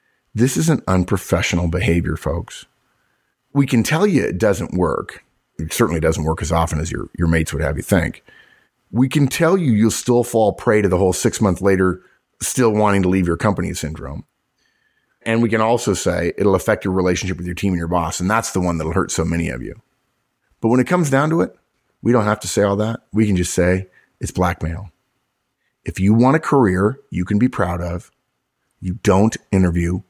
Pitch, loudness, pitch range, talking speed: 95 Hz, -18 LUFS, 85-115 Hz, 210 wpm